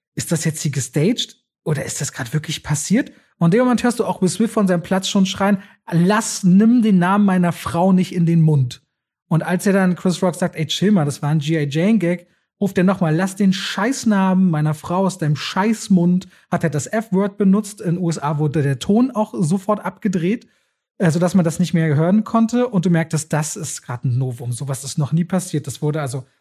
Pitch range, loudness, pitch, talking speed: 155-200 Hz, -18 LUFS, 180 Hz, 220 wpm